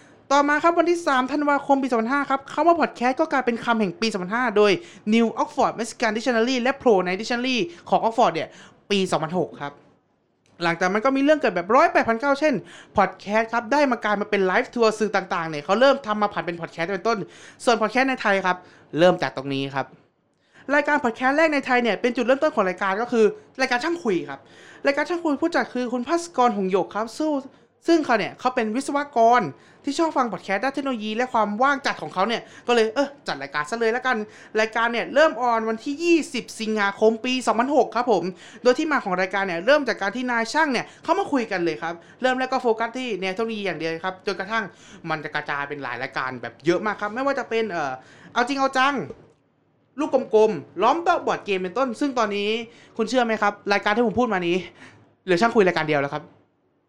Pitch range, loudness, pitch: 195-265 Hz, -22 LUFS, 230 Hz